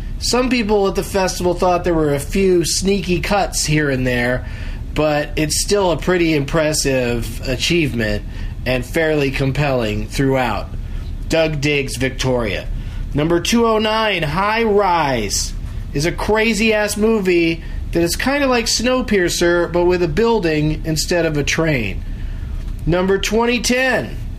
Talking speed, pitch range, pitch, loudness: 135 wpm, 125-195 Hz, 160 Hz, -17 LUFS